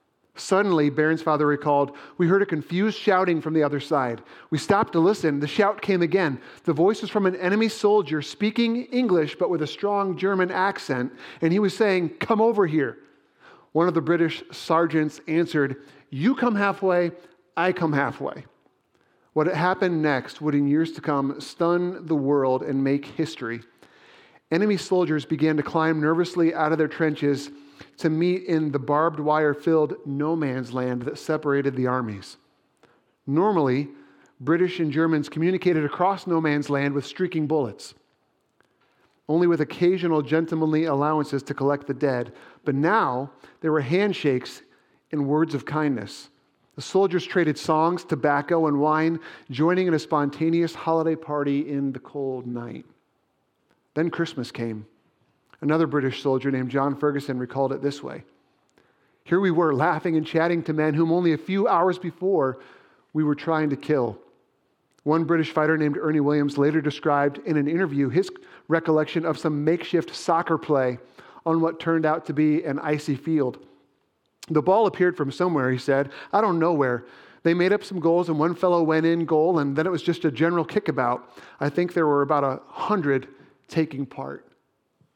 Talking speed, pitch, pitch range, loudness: 170 wpm, 155 Hz, 145-175 Hz, -23 LUFS